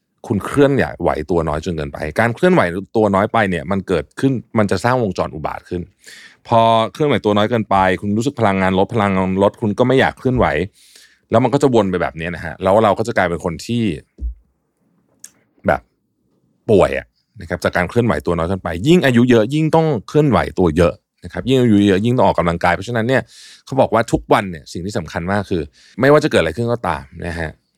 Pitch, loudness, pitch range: 100 Hz, -16 LUFS, 90-120 Hz